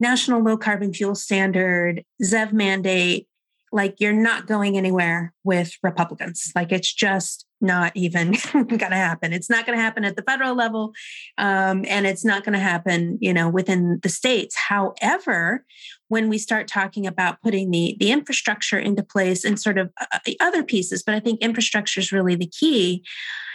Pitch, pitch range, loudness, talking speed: 200 Hz, 185-220 Hz, -21 LUFS, 175 wpm